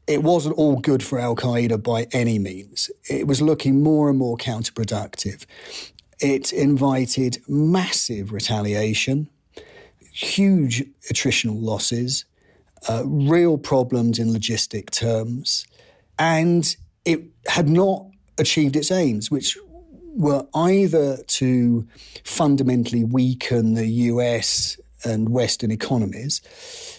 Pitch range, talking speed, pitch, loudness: 115-155 Hz, 105 wpm, 130 Hz, -21 LUFS